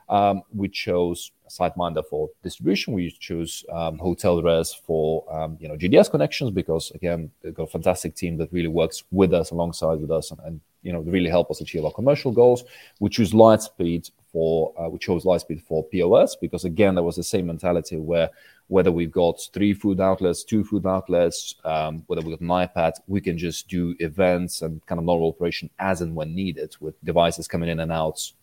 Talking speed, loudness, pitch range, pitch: 205 wpm, -23 LUFS, 80-95 Hz, 85 Hz